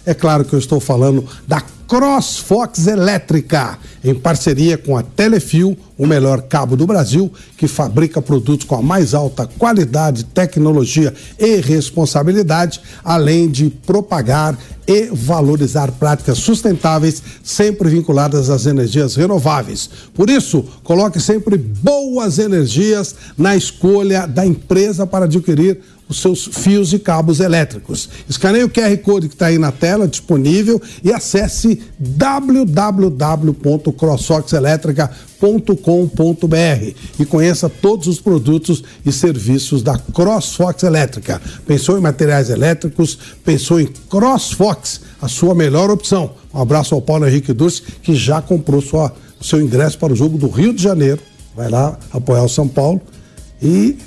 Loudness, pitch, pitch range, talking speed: -14 LUFS, 160 Hz, 145-190 Hz, 135 wpm